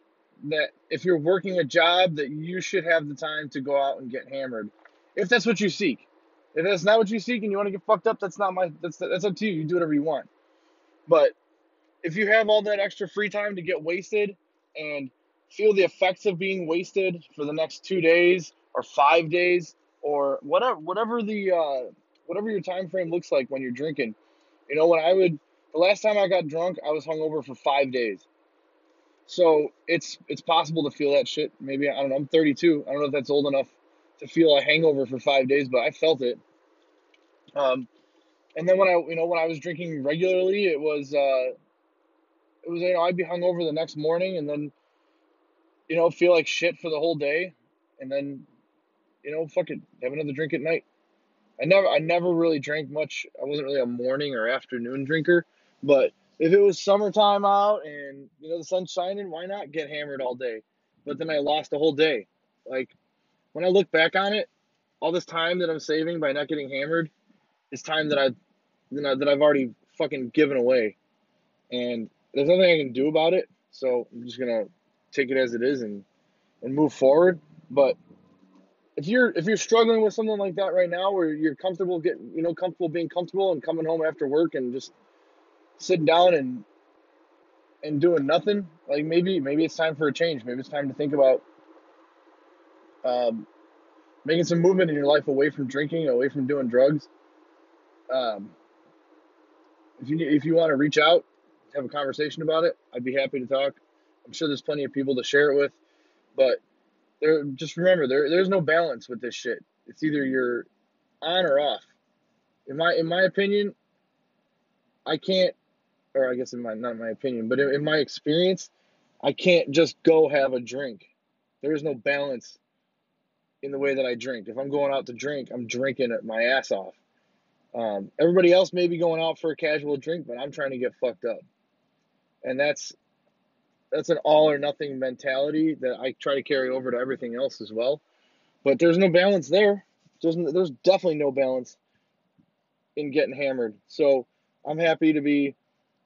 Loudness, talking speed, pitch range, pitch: -24 LUFS, 200 wpm, 140-185 Hz, 160 Hz